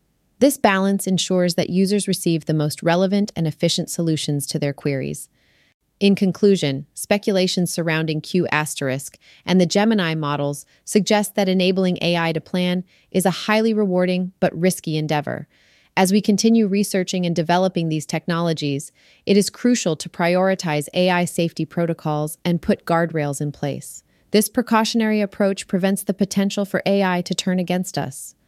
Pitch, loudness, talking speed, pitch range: 180 Hz, -20 LUFS, 150 wpm, 160-195 Hz